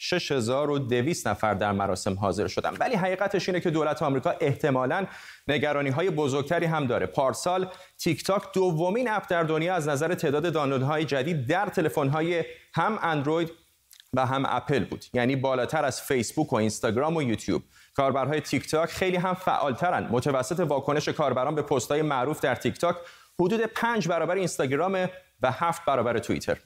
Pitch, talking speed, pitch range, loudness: 155 Hz, 160 wpm, 135-180 Hz, -27 LUFS